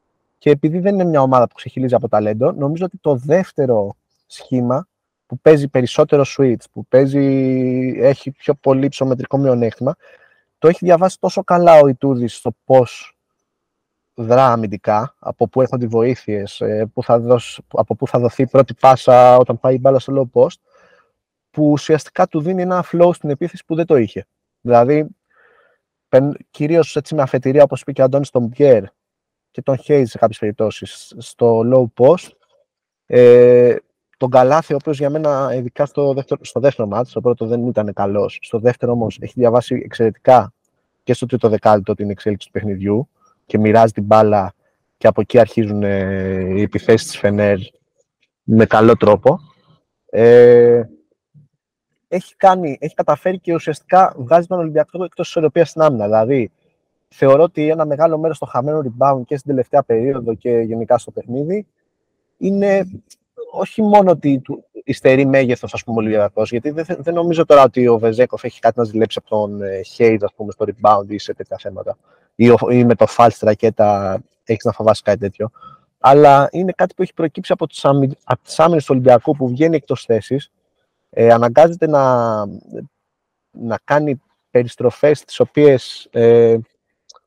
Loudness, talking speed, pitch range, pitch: -15 LUFS, 160 wpm, 115-150 Hz, 130 Hz